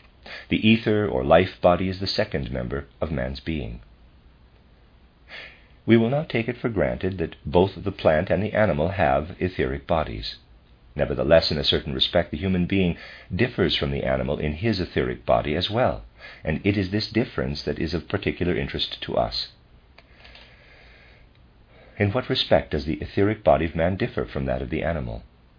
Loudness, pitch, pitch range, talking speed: -24 LUFS, 80 Hz, 65-95 Hz, 175 wpm